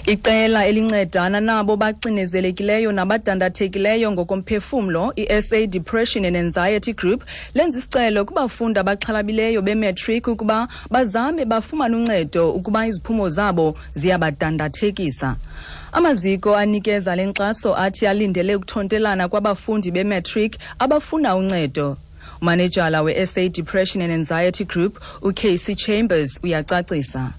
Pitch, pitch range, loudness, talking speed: 205 Hz, 180-220 Hz, -19 LUFS, 95 wpm